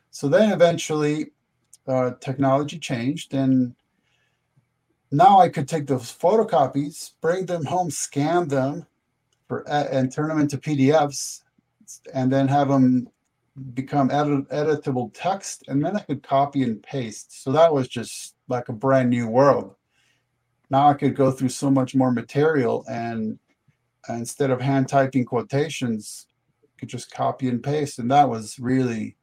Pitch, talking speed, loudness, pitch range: 135 Hz, 150 wpm, -22 LUFS, 125-145 Hz